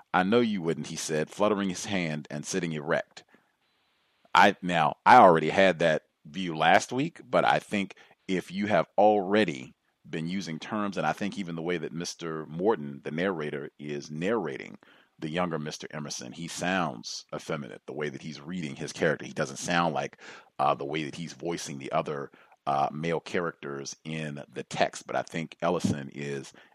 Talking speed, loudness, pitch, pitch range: 180 wpm, -28 LUFS, 80 Hz, 75-95 Hz